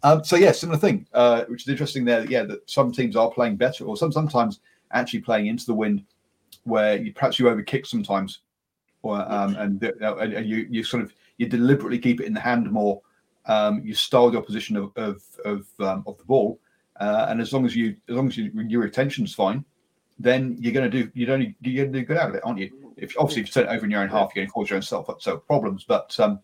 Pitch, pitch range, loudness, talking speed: 120 Hz, 110-135 Hz, -23 LUFS, 245 wpm